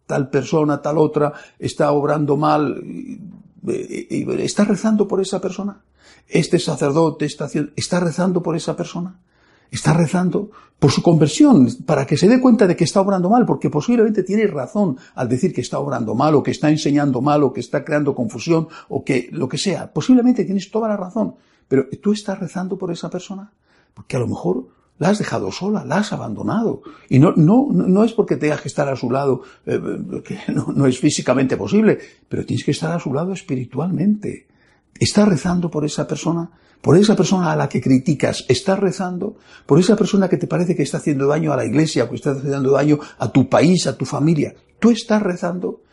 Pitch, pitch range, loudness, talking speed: 170 Hz, 145-195 Hz, -18 LUFS, 200 wpm